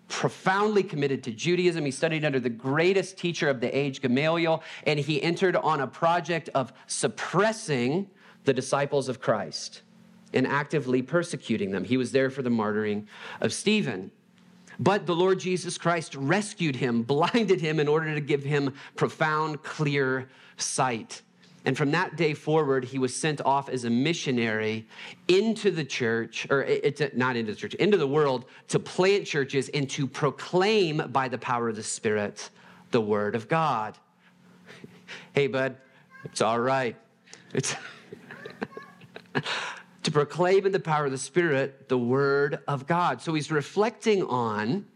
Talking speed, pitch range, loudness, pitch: 155 wpm, 130-180 Hz, -27 LUFS, 150 Hz